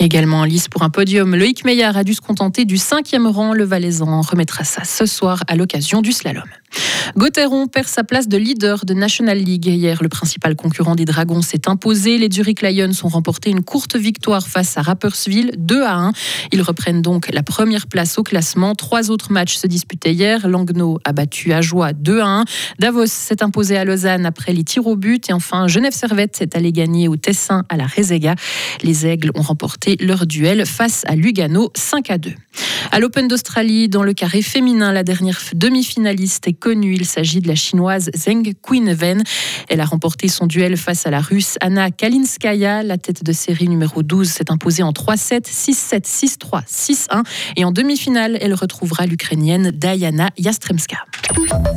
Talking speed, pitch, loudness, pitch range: 190 wpm, 190 Hz, -15 LUFS, 170-215 Hz